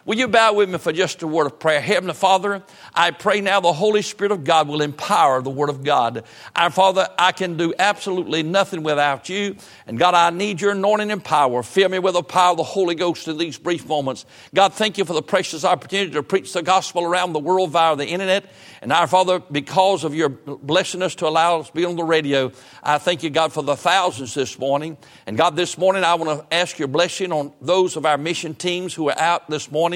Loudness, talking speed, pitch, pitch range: -19 LUFS, 240 wpm, 175 Hz, 155-190 Hz